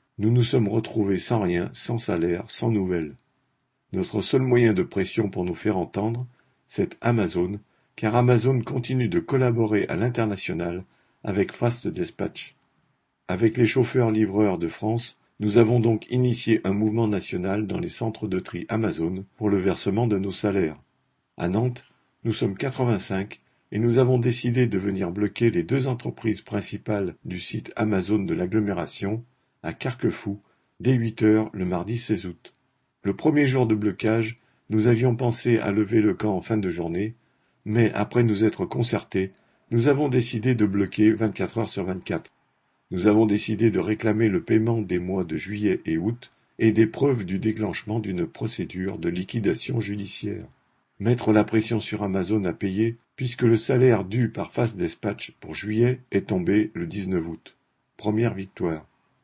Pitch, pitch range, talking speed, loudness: 110 Hz, 100-120 Hz, 165 wpm, -24 LUFS